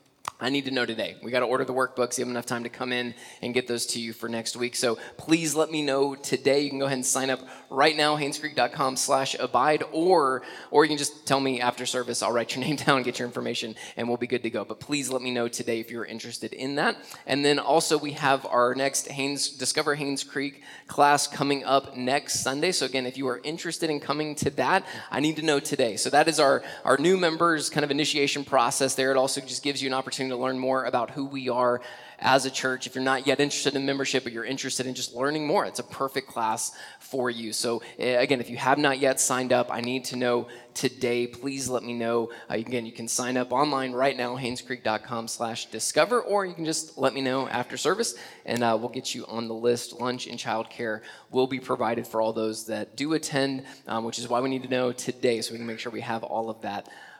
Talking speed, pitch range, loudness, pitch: 250 wpm, 120-140 Hz, -26 LUFS, 130 Hz